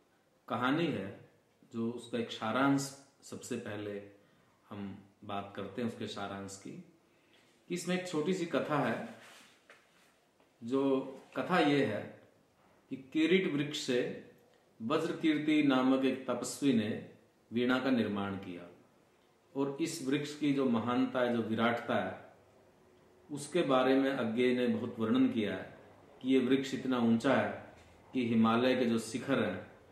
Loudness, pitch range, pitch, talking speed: -33 LUFS, 115-140 Hz, 125 Hz, 145 wpm